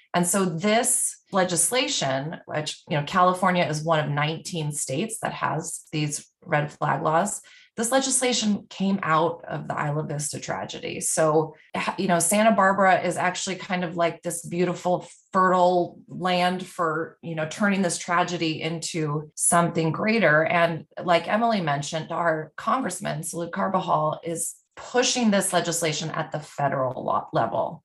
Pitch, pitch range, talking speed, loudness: 170 Hz, 160-185 Hz, 145 wpm, -24 LUFS